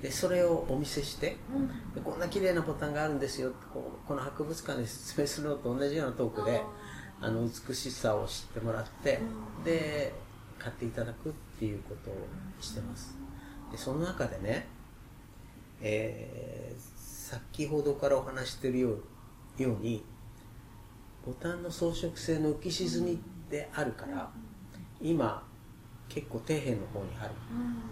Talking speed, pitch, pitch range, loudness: 285 characters per minute, 125 Hz, 115-150 Hz, -35 LUFS